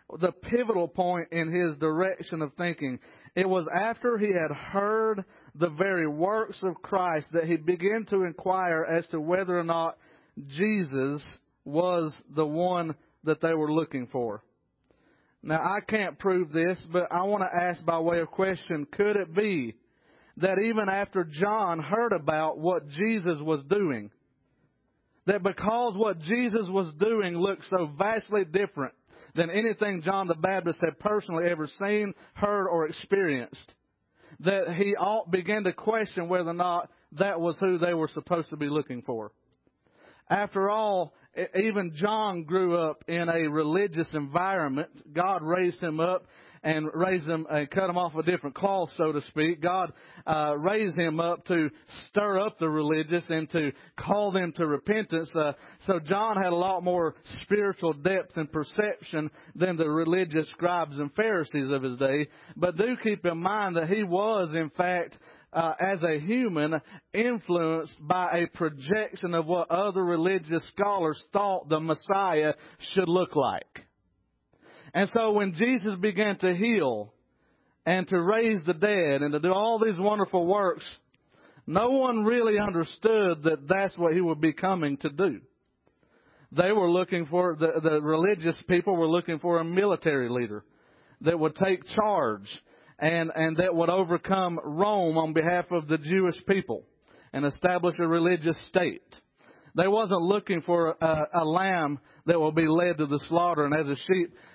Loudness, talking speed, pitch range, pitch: -27 LUFS, 160 wpm, 160-195 Hz, 175 Hz